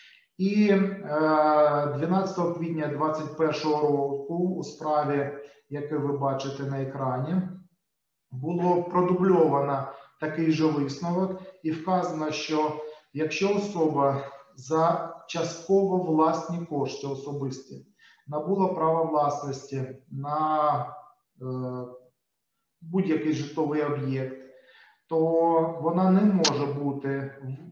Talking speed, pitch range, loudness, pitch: 85 wpm, 140-170 Hz, -26 LUFS, 155 Hz